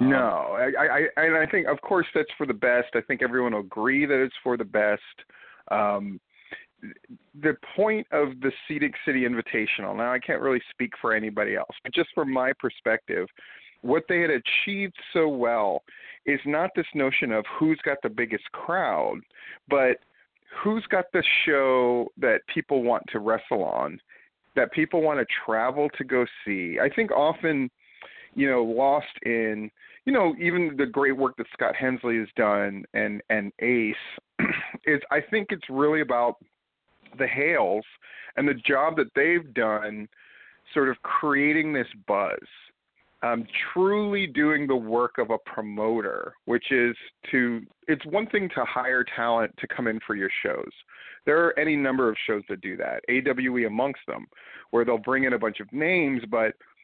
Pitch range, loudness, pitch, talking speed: 115-150 Hz, -25 LUFS, 130 Hz, 170 wpm